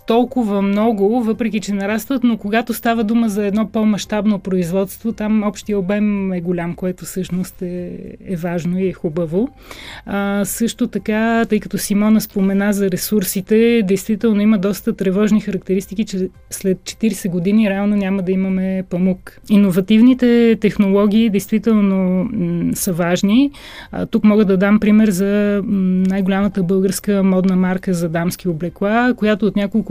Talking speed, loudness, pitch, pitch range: 150 wpm, -17 LUFS, 200 Hz, 190-220 Hz